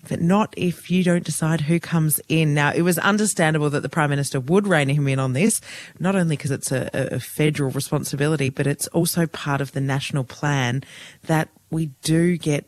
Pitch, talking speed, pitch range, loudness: 155 Hz, 205 wpm, 140-170 Hz, -21 LUFS